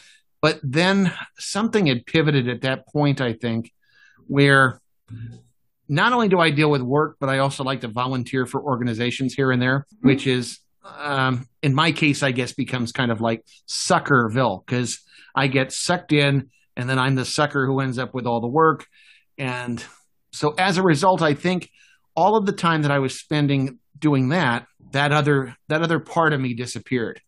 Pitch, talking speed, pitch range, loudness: 135 Hz, 185 wpm, 125-155 Hz, -21 LUFS